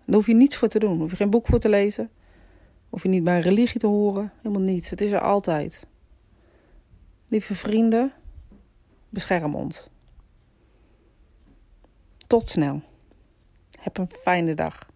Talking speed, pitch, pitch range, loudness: 150 wpm, 200 Hz, 160-220 Hz, -23 LUFS